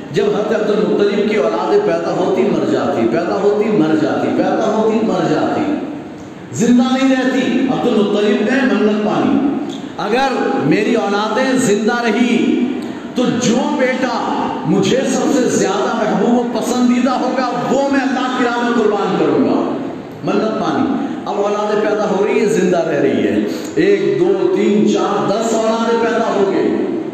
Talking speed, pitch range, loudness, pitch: 150 wpm, 215-275 Hz, -15 LUFS, 245 Hz